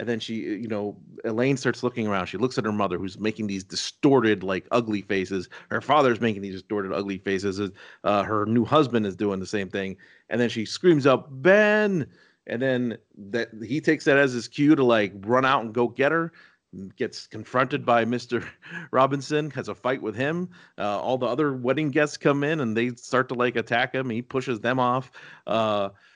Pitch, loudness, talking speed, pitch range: 120 Hz, -25 LUFS, 205 wpm, 105-130 Hz